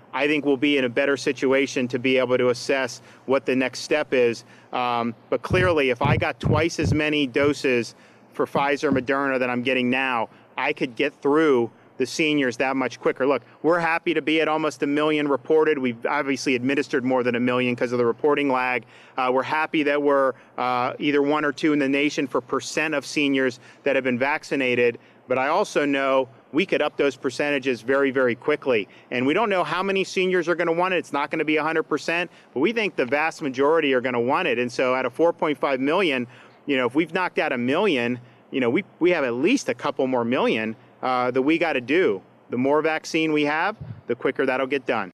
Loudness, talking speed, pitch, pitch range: -22 LUFS, 225 wpm, 135 Hz, 125-150 Hz